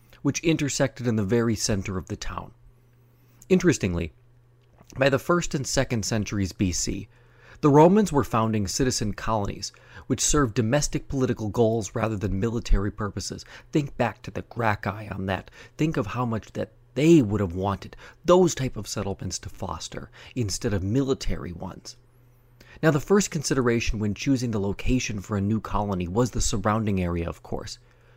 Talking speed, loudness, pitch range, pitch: 160 wpm, -25 LUFS, 100-130 Hz, 115 Hz